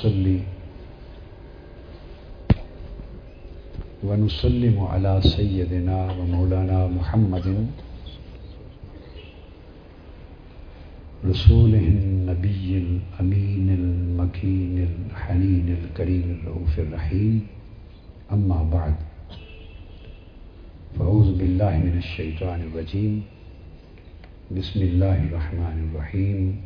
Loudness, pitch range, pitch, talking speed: -23 LUFS, 85-95 Hz, 90 Hz, 55 wpm